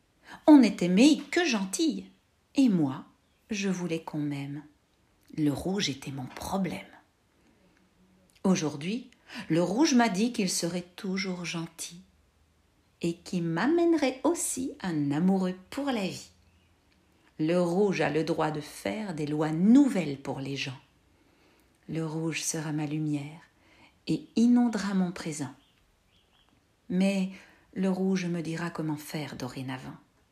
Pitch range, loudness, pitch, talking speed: 145-195 Hz, -28 LUFS, 170 Hz, 125 wpm